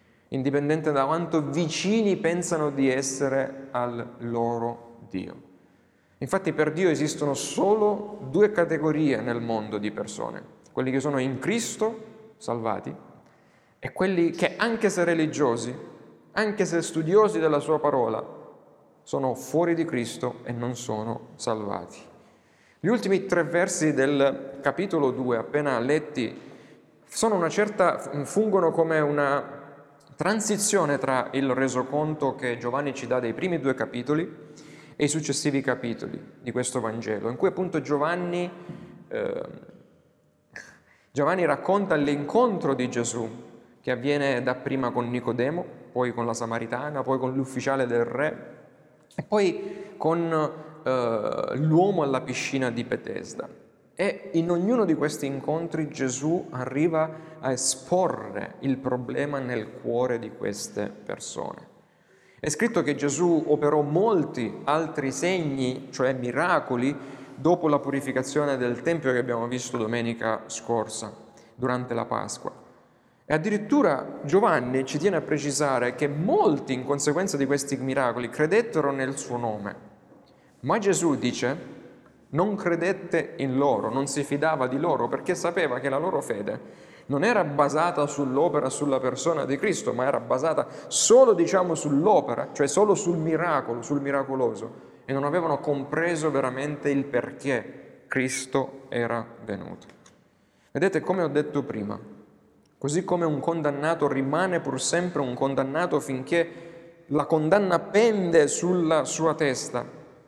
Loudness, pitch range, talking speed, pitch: -26 LUFS, 130-170 Hz, 130 wpm, 145 Hz